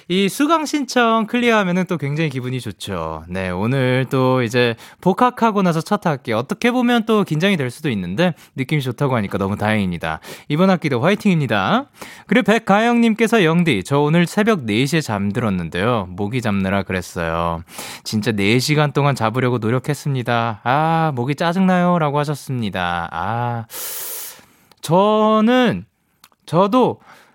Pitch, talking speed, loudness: 150 Hz, 320 characters per minute, -18 LUFS